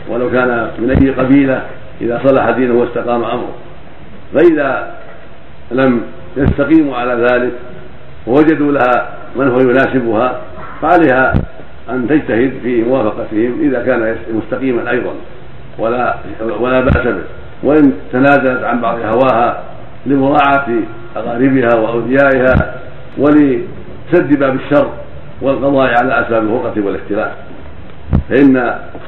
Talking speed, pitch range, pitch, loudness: 105 wpm, 120-140 Hz, 130 Hz, -13 LUFS